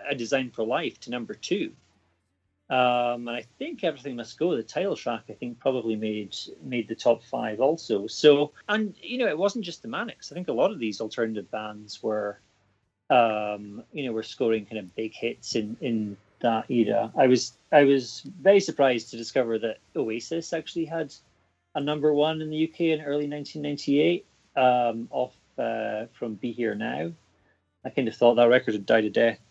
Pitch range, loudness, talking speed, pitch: 110-145 Hz, -26 LUFS, 195 wpm, 120 Hz